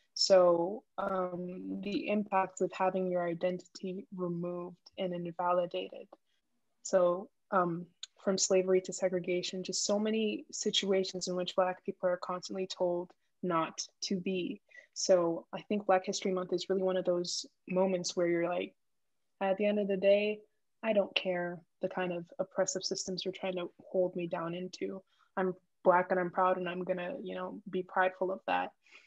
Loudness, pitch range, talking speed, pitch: -33 LUFS, 180-190 Hz, 170 wpm, 185 Hz